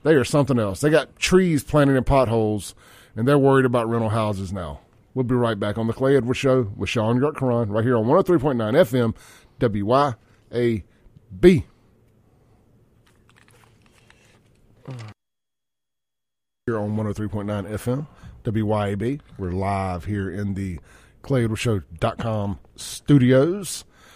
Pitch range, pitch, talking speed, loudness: 105-130 Hz, 115 Hz, 115 wpm, -21 LUFS